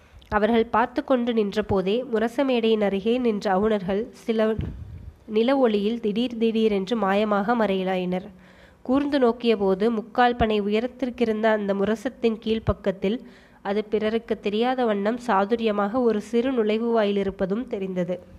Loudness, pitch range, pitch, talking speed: -23 LUFS, 205-235 Hz, 220 Hz, 110 wpm